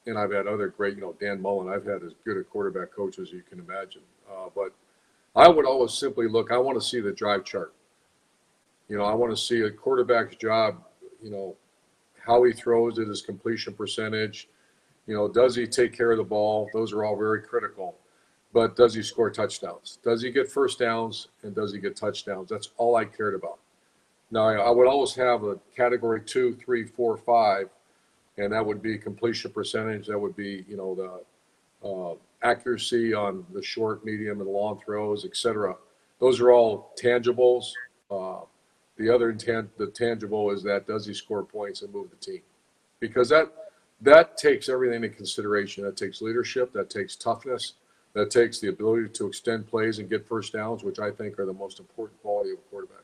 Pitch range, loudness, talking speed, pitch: 105-125 Hz, -25 LUFS, 200 wpm, 115 Hz